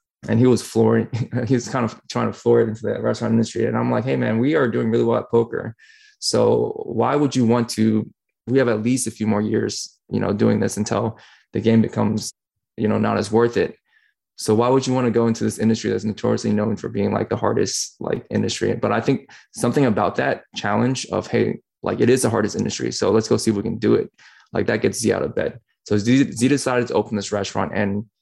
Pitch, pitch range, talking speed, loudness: 115 Hz, 110-125 Hz, 245 wpm, -20 LUFS